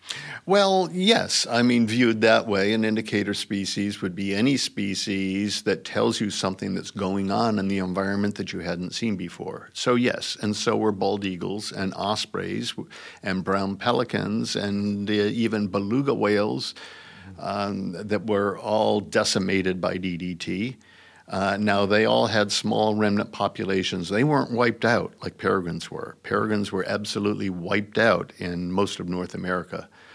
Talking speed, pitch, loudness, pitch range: 155 wpm, 100 Hz, -24 LUFS, 95-110 Hz